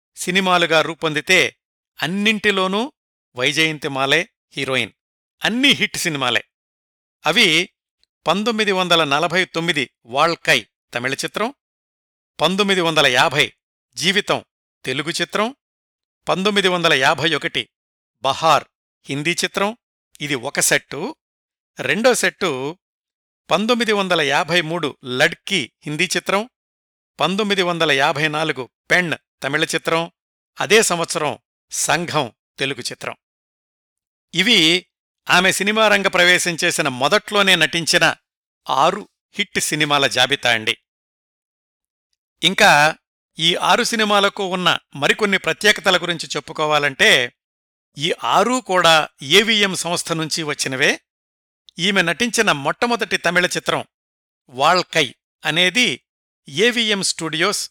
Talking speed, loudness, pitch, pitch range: 95 wpm, -17 LUFS, 170 Hz, 150-195 Hz